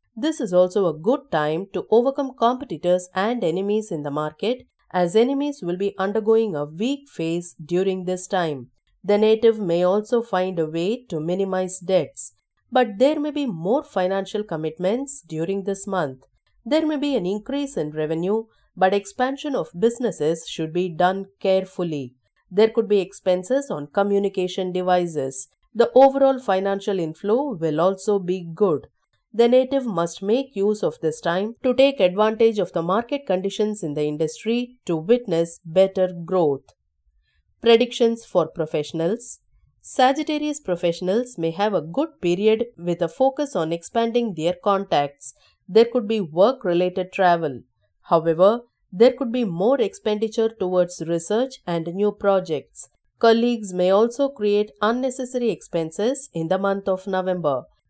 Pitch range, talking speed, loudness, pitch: 170-230 Hz, 145 wpm, -22 LUFS, 195 Hz